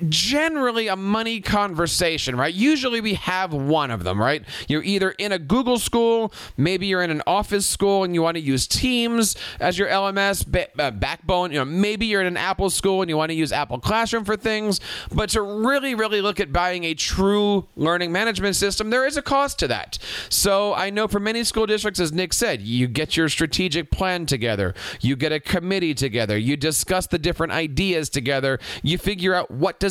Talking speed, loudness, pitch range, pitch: 205 wpm, -21 LUFS, 160-210 Hz, 185 Hz